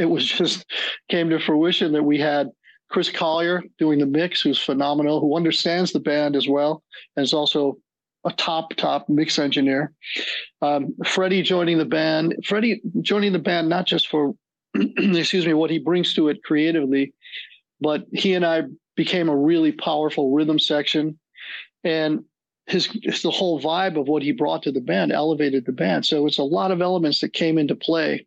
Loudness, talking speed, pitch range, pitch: -21 LUFS, 185 wpm, 150-175 Hz, 155 Hz